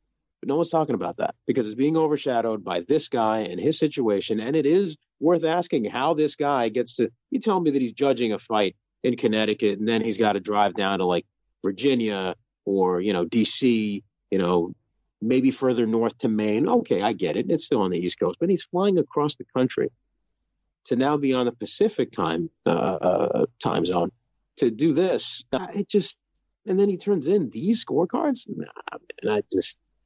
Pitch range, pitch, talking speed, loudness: 110-165 Hz, 130 Hz, 200 wpm, -24 LUFS